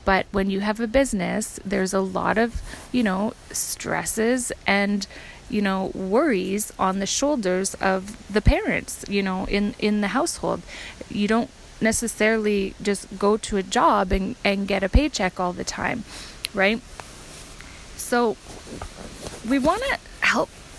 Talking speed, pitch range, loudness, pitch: 145 wpm, 195-230 Hz, -23 LUFS, 205 Hz